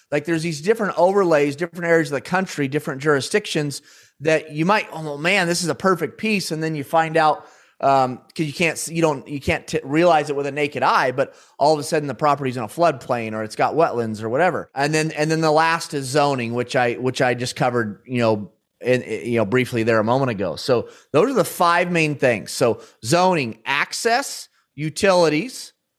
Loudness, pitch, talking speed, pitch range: -20 LUFS, 150 Hz, 215 wpm, 130-165 Hz